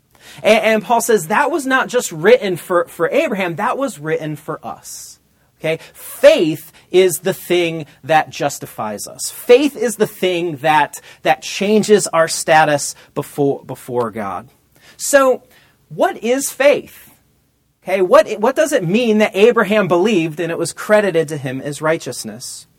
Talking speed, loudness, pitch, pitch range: 150 wpm, -16 LUFS, 180 Hz, 155-220 Hz